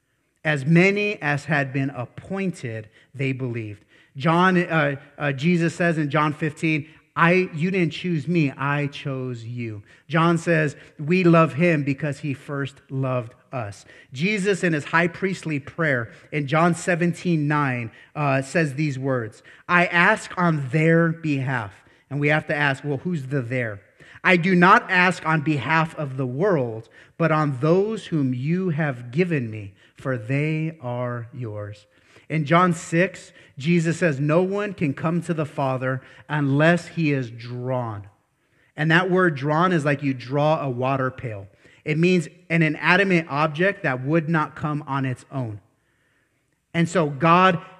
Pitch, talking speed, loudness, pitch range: 150 Hz, 155 wpm, -22 LUFS, 130-170 Hz